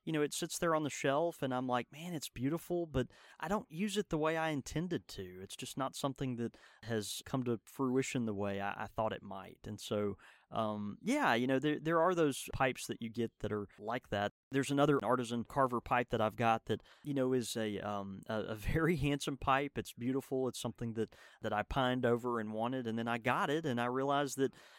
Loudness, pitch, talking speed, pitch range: -36 LUFS, 125 Hz, 235 wpm, 110-140 Hz